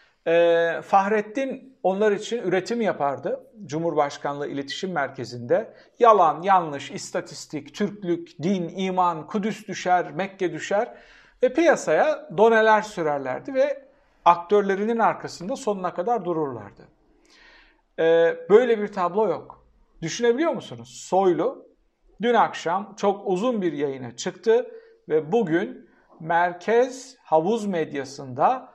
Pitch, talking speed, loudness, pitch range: 185 Hz, 100 wpm, -23 LUFS, 160-230 Hz